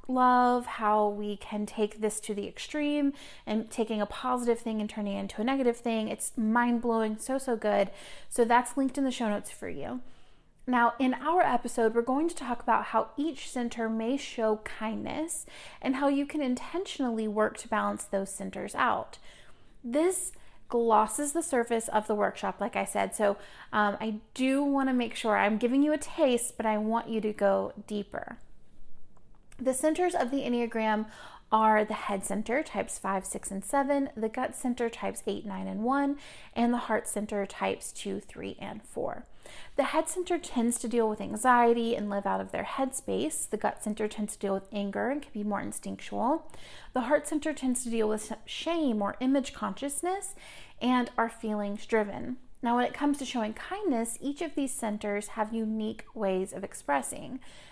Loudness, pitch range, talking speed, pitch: -30 LUFS, 215-270 Hz, 190 wpm, 235 Hz